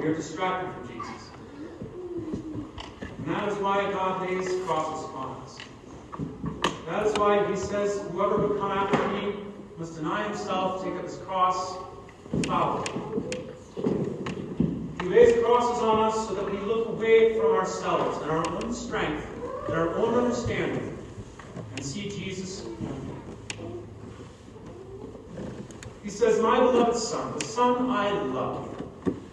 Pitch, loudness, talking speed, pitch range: 200 Hz, -27 LUFS, 135 wpm, 180-220 Hz